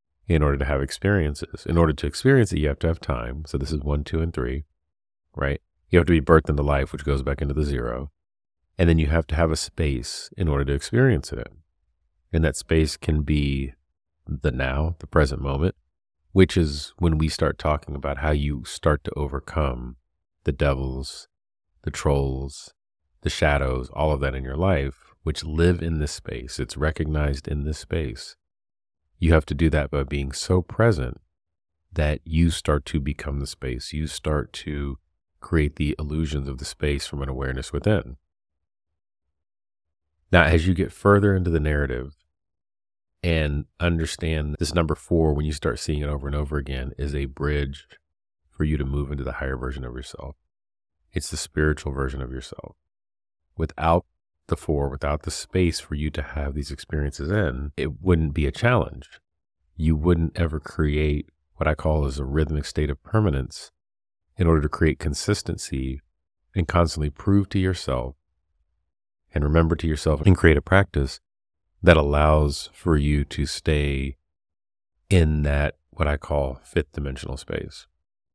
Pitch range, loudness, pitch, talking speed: 70-80 Hz, -24 LUFS, 75 Hz, 175 wpm